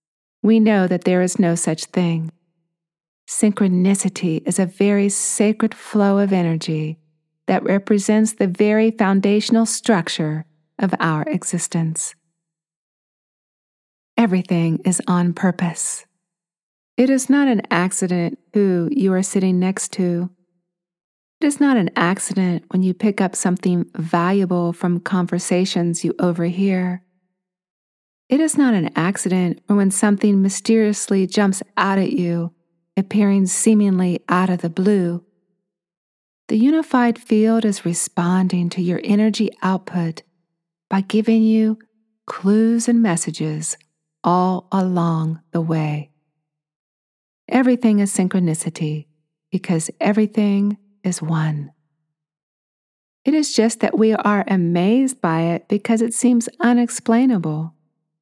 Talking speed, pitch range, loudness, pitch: 115 wpm, 170-210 Hz, -18 LUFS, 185 Hz